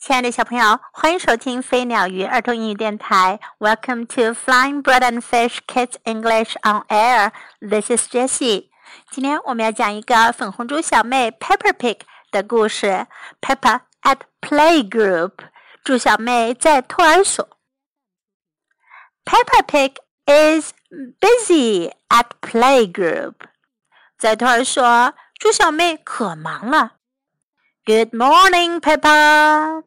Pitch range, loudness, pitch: 225-305 Hz, -16 LUFS, 250 Hz